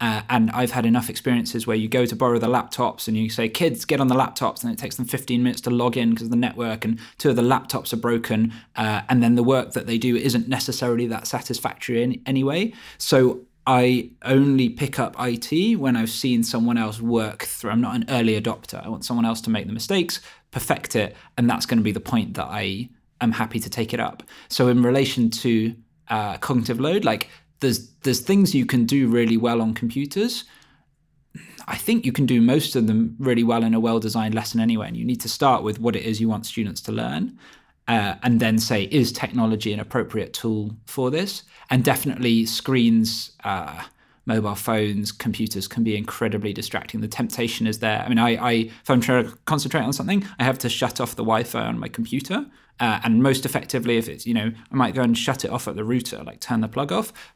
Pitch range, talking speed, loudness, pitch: 115-130 Hz, 225 wpm, -22 LUFS, 120 Hz